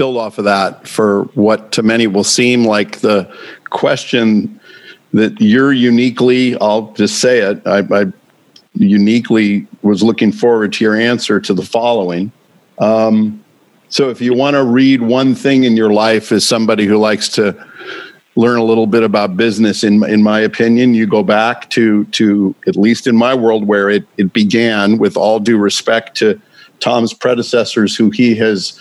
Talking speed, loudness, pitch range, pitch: 175 wpm, -12 LUFS, 105-120 Hz, 110 Hz